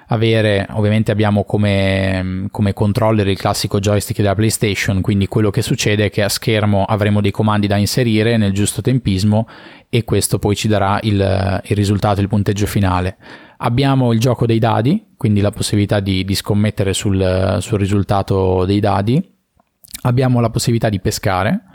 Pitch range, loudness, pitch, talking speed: 100-115 Hz, -16 LUFS, 105 Hz, 165 wpm